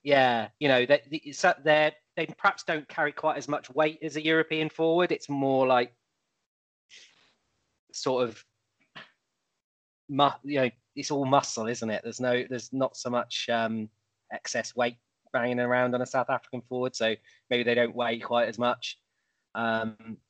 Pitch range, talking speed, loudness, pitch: 120-145 Hz, 165 wpm, -28 LUFS, 125 Hz